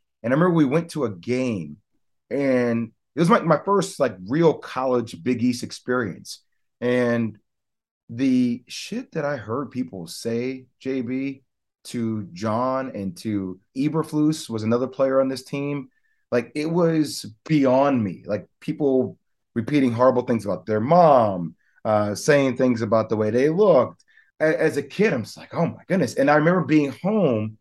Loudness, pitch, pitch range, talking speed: -22 LUFS, 130 Hz, 115-150 Hz, 165 wpm